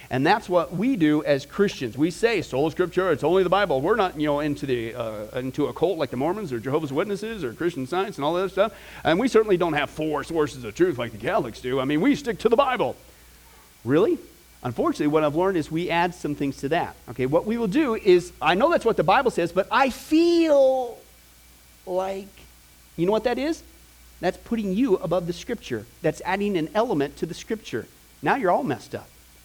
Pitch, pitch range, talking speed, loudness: 175 Hz, 140-215 Hz, 225 wpm, -24 LUFS